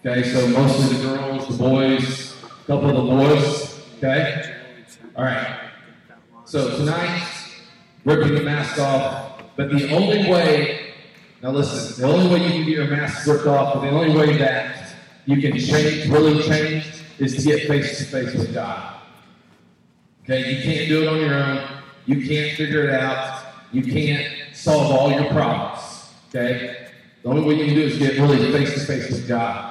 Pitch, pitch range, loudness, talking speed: 140 Hz, 130-150 Hz, -20 LUFS, 175 wpm